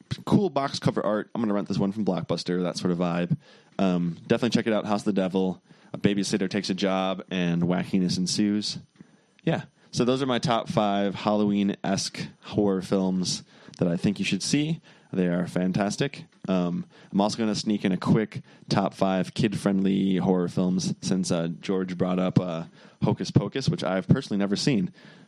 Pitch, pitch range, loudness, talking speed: 100 Hz, 90-105 Hz, -26 LUFS, 190 wpm